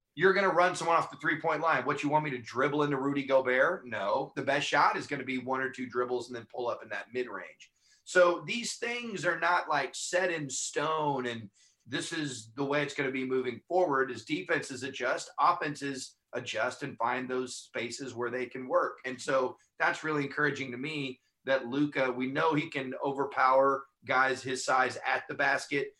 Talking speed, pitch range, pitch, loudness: 205 wpm, 130-160 Hz, 140 Hz, -31 LUFS